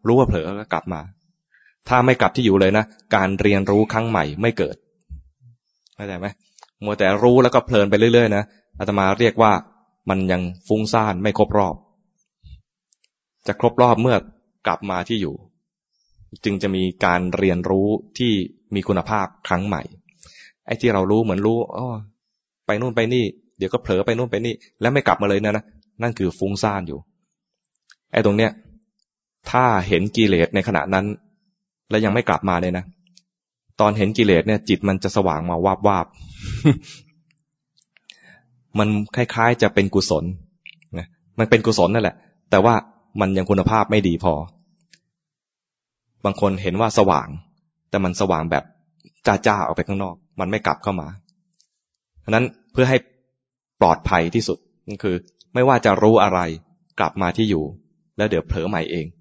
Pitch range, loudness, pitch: 95-120 Hz, -20 LUFS, 105 Hz